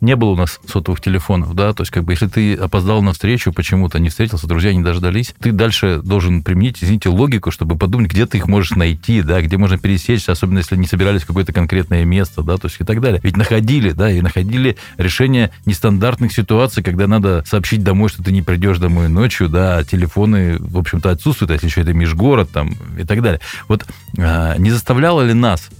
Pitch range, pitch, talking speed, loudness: 90-110 Hz, 95 Hz, 210 wpm, -15 LUFS